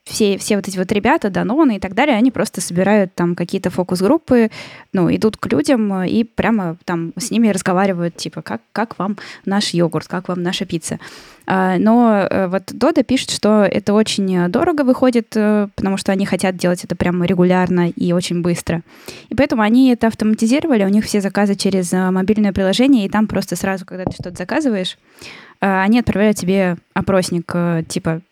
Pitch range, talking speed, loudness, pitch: 180-220 Hz, 175 wpm, -17 LUFS, 195 Hz